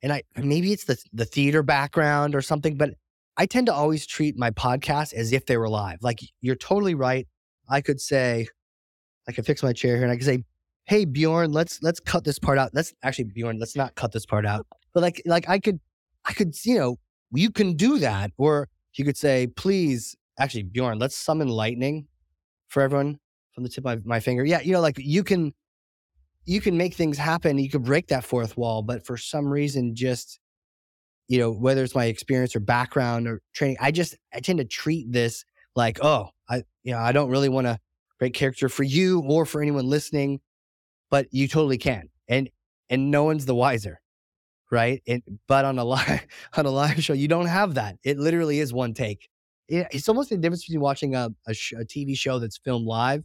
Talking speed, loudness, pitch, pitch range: 215 wpm, -24 LUFS, 135 Hz, 115-150 Hz